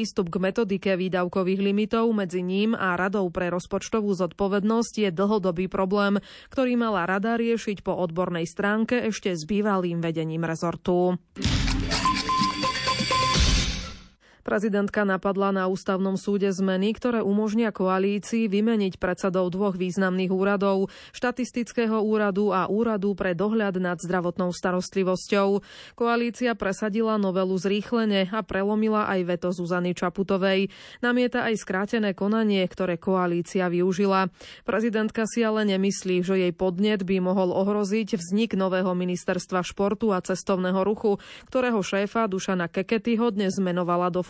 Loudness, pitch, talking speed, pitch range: -25 LUFS, 195 Hz, 125 wpm, 185-215 Hz